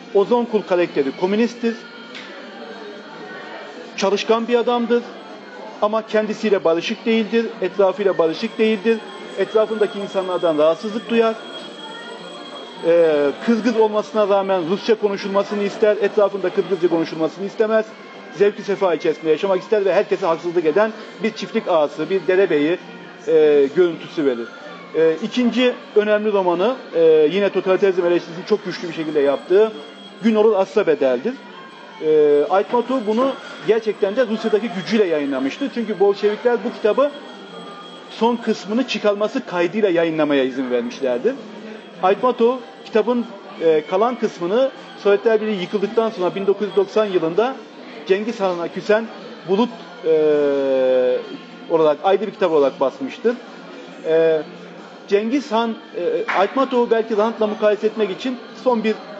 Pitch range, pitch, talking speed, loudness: 185-230 Hz, 210 Hz, 120 wpm, -19 LUFS